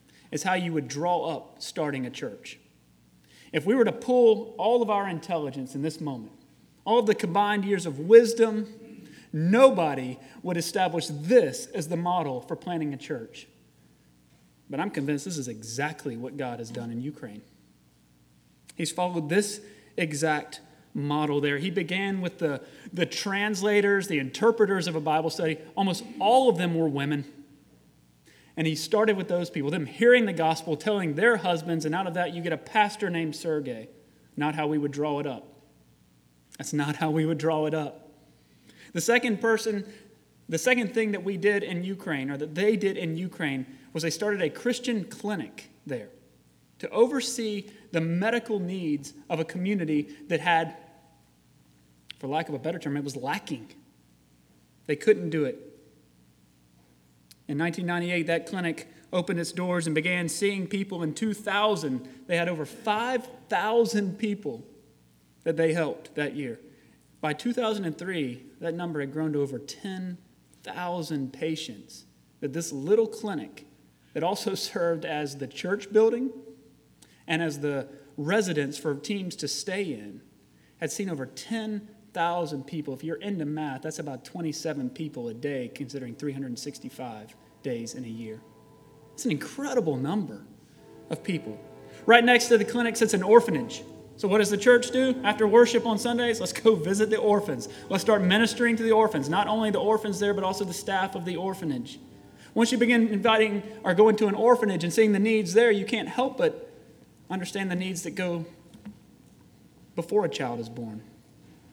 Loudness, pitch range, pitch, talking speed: -27 LUFS, 145-210 Hz, 165 Hz, 165 wpm